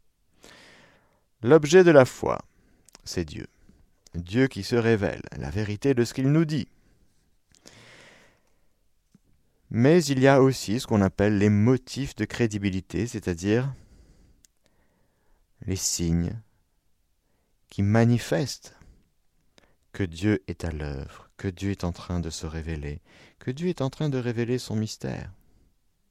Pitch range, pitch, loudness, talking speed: 85-125 Hz, 105 Hz, -25 LUFS, 130 wpm